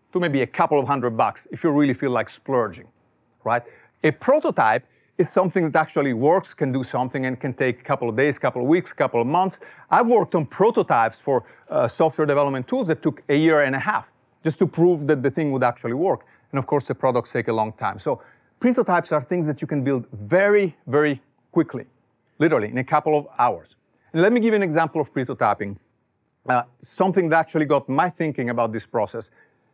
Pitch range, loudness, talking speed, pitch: 125-160 Hz, -22 LUFS, 220 wpm, 145 Hz